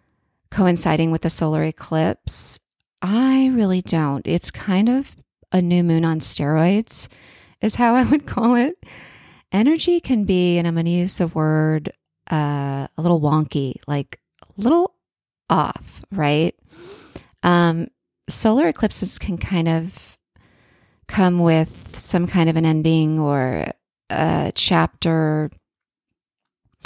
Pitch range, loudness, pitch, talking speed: 155-205 Hz, -19 LUFS, 170 Hz, 125 wpm